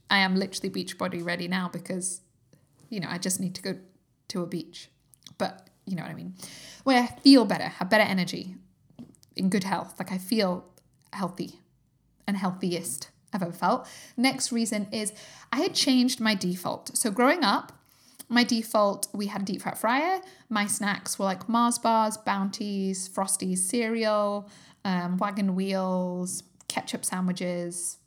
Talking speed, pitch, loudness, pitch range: 165 wpm, 195 Hz, -27 LUFS, 180-220 Hz